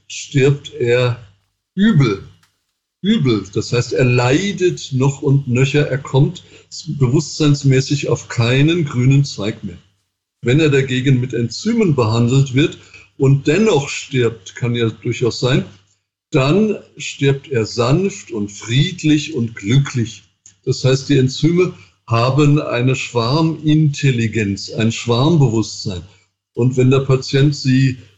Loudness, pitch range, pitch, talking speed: -16 LUFS, 115-145 Hz, 130 Hz, 115 wpm